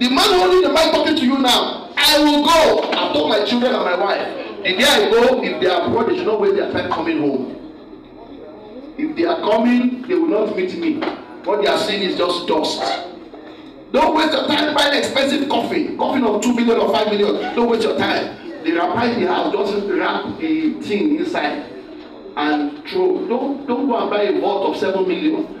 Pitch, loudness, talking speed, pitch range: 305 Hz, -17 LUFS, 205 wpm, 245-335 Hz